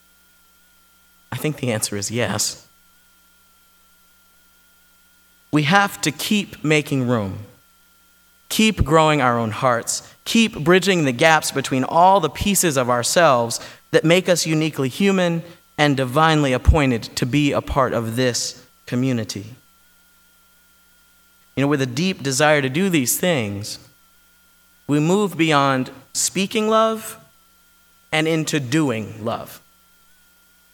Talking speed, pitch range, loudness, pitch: 120 wpm, 135-195 Hz, -19 LUFS, 165 Hz